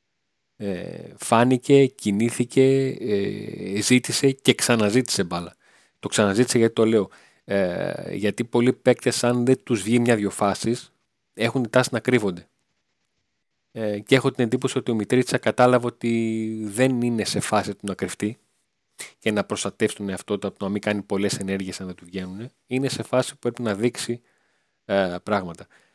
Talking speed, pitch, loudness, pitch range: 160 wpm, 115 Hz, -23 LUFS, 100-125 Hz